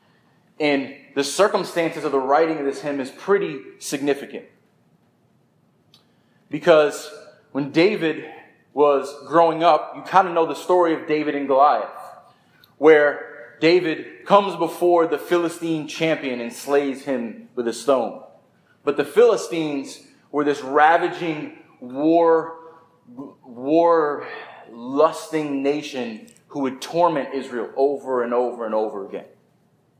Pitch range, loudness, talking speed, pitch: 140-165 Hz, -20 LUFS, 120 wpm, 150 Hz